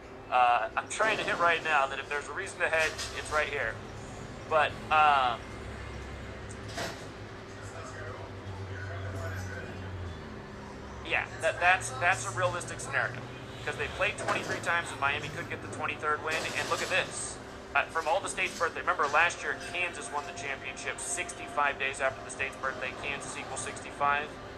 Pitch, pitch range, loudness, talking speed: 130 Hz, 100-145 Hz, -30 LUFS, 155 wpm